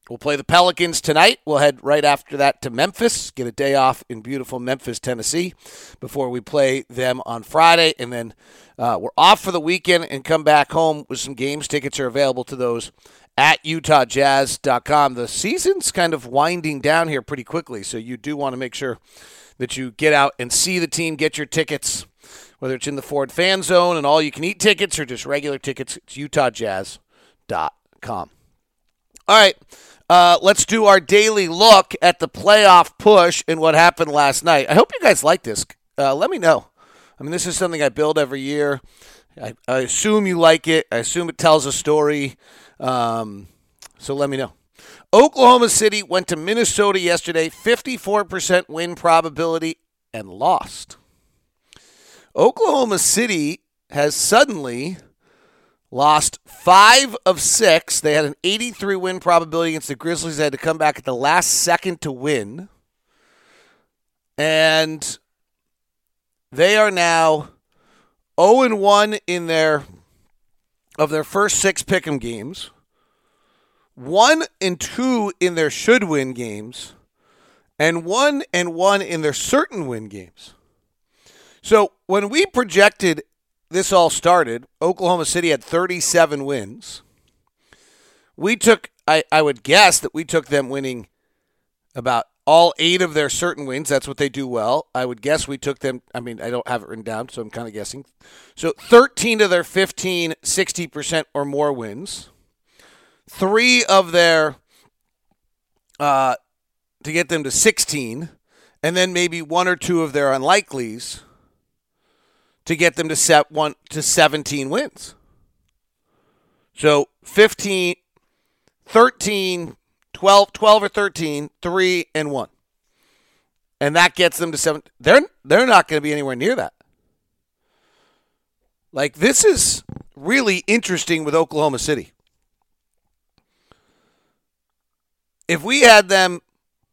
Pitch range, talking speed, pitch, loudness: 135-180 Hz, 150 wpm, 155 Hz, -17 LUFS